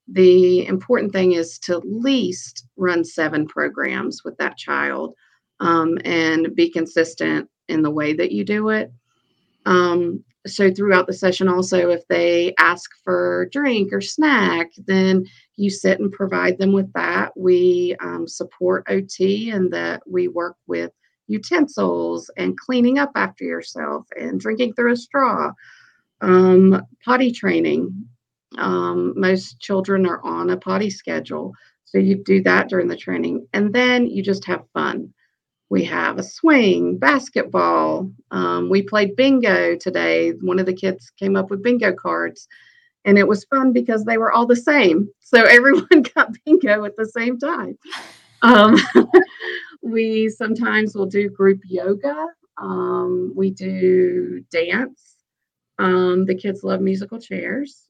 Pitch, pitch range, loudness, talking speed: 190 Hz, 175-220 Hz, -18 LUFS, 145 wpm